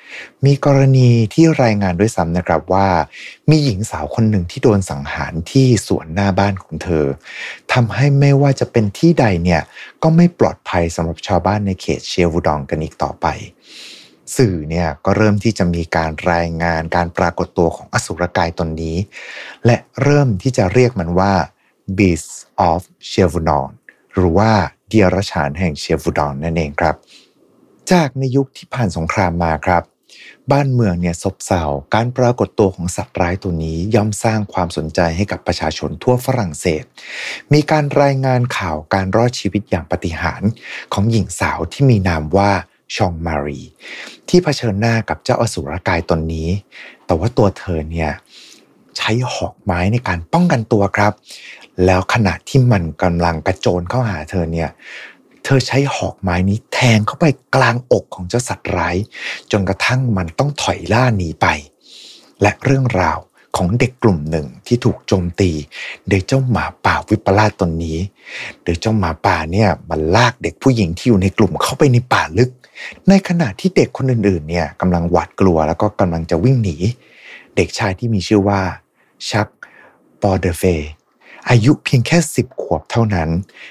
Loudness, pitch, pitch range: -16 LUFS, 95 Hz, 85-120 Hz